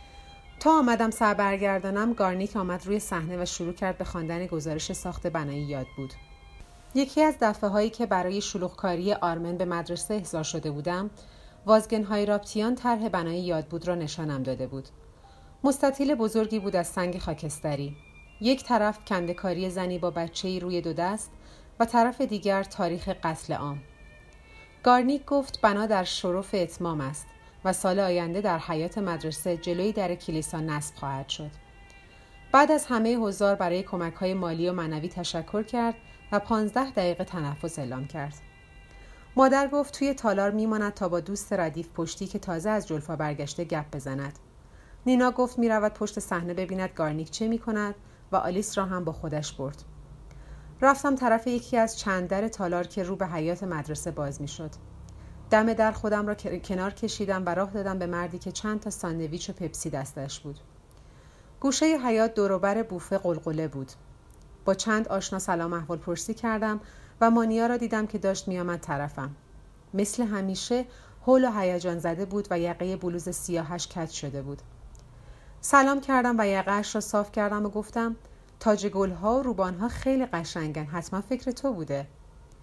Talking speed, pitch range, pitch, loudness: 160 wpm, 165-215 Hz, 185 Hz, -28 LUFS